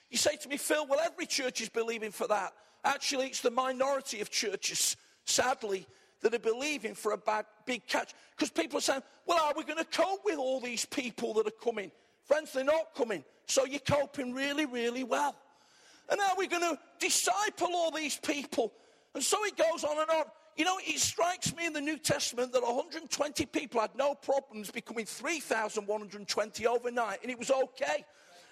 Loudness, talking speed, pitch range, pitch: -32 LUFS, 195 wpm, 240-315 Hz, 280 Hz